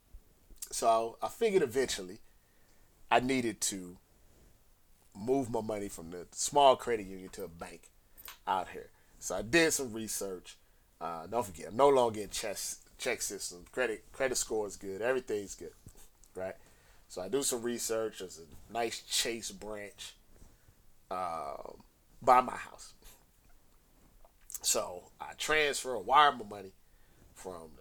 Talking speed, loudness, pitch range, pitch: 140 wpm, -32 LUFS, 95-115 Hz, 105 Hz